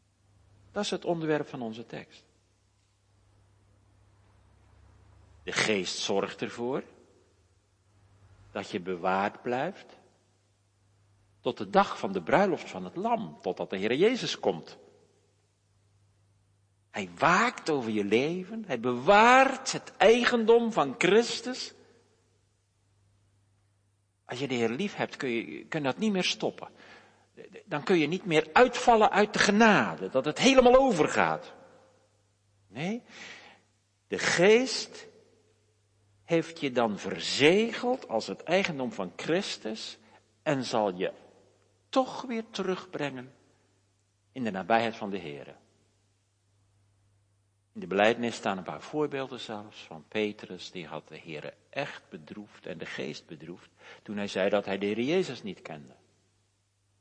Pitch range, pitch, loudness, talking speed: 100-155 Hz, 105 Hz, -28 LUFS, 125 wpm